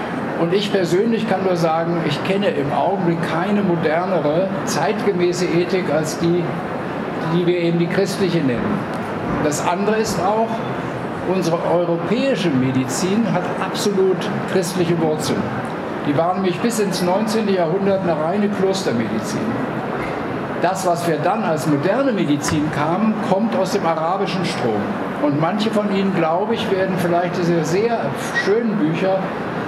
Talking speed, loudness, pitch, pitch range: 140 wpm, -19 LUFS, 180 Hz, 170-200 Hz